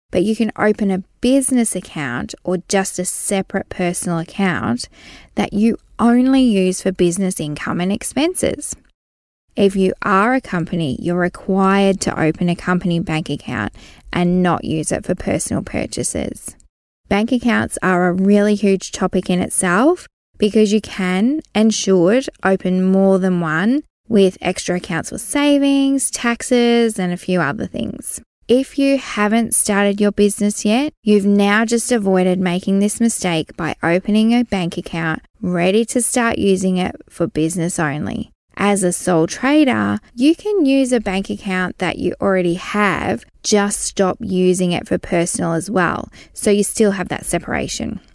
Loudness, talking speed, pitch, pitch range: -17 LUFS, 155 wpm, 195 Hz, 175-225 Hz